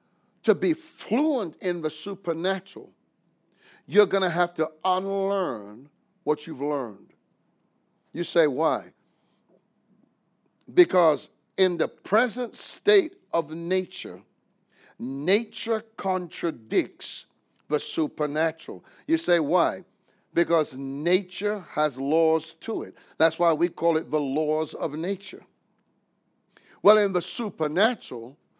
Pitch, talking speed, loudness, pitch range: 180 Hz, 105 wpm, -25 LUFS, 160-200 Hz